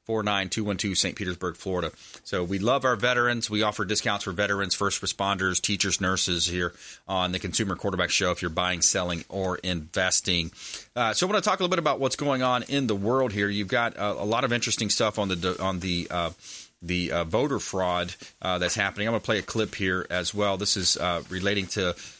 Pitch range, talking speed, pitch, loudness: 90-105 Hz, 230 wpm, 100 Hz, -25 LUFS